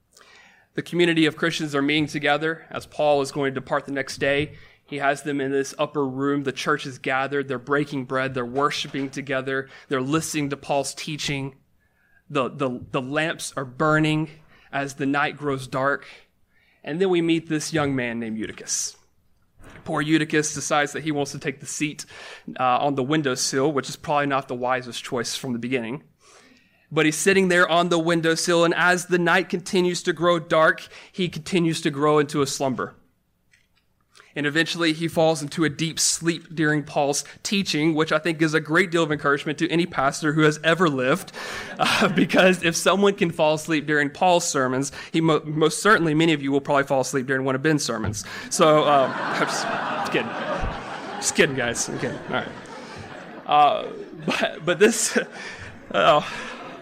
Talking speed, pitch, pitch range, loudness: 185 wpm, 150 Hz, 140-165 Hz, -22 LUFS